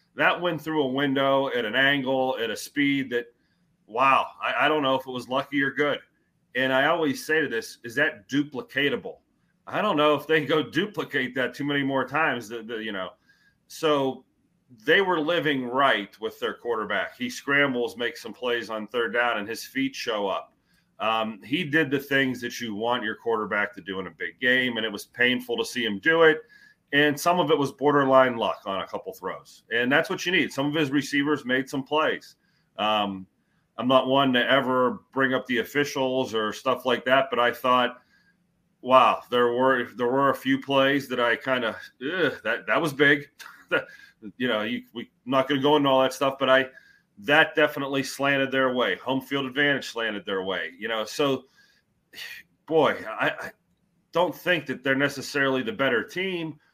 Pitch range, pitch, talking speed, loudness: 125-150 Hz, 135 Hz, 200 wpm, -24 LUFS